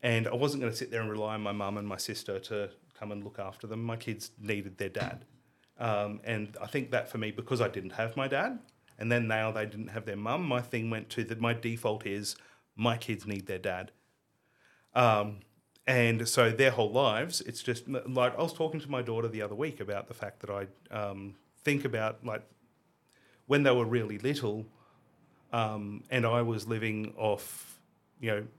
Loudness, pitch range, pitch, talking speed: -32 LUFS, 105-125 Hz, 115 Hz, 210 wpm